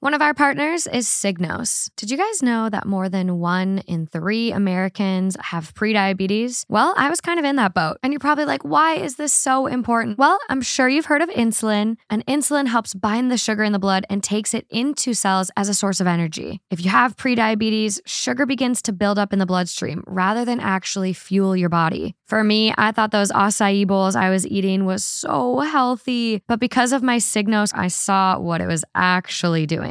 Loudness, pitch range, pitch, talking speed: -19 LUFS, 190-250 Hz, 215 Hz, 210 wpm